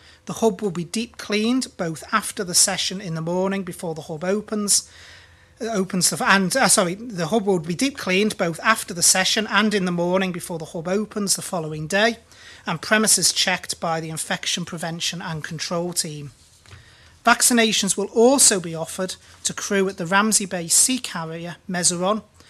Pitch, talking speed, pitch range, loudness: 185 Hz, 180 wpm, 170-210 Hz, -20 LUFS